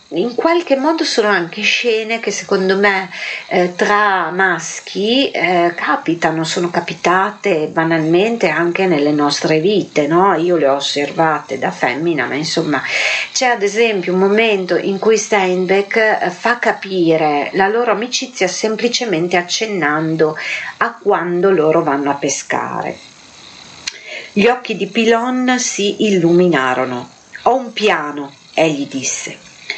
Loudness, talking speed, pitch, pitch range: -15 LUFS, 125 wpm, 190 Hz, 165-220 Hz